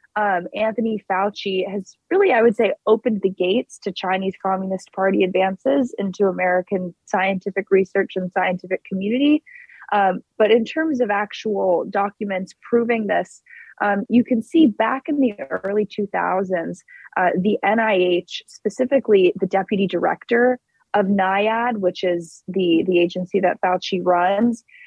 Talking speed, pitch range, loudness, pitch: 140 wpm, 190-230 Hz, -20 LUFS, 200 Hz